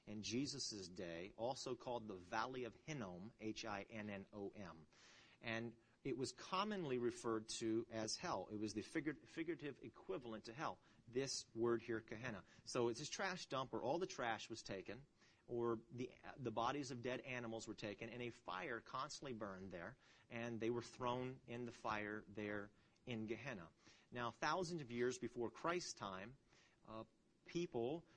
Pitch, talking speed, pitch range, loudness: 115 Hz, 160 wpm, 110-130 Hz, -48 LUFS